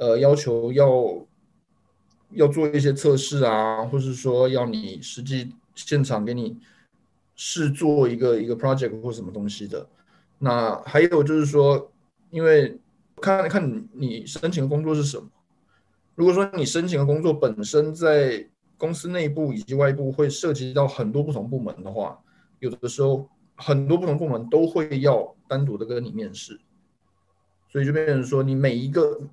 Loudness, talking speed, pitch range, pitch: -22 LUFS, 250 characters per minute, 120-155 Hz, 140 Hz